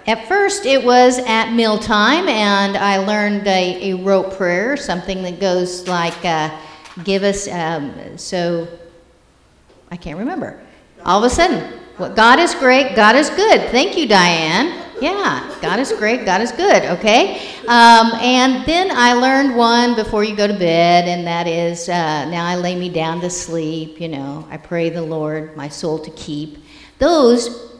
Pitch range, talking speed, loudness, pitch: 170-240 Hz, 175 wpm, -15 LUFS, 195 Hz